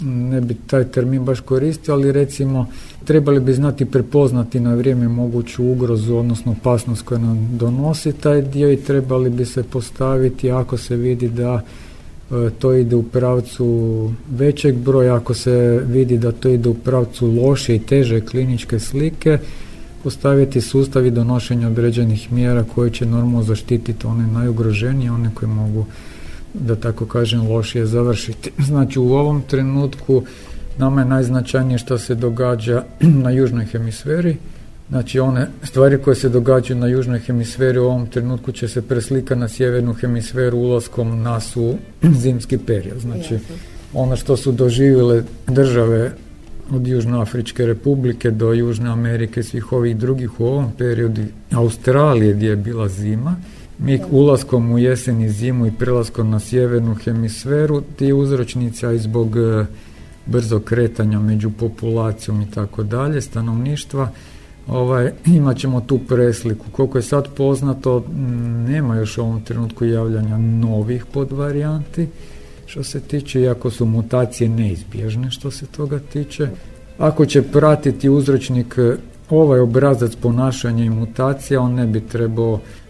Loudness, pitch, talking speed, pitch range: -17 LUFS, 125 Hz, 140 wpm, 115-130 Hz